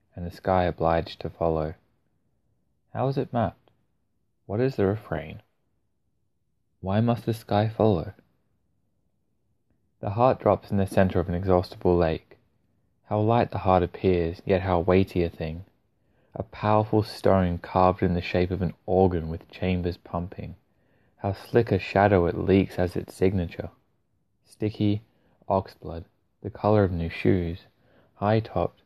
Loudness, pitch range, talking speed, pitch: -25 LUFS, 90-110 Hz, 150 wpm, 95 Hz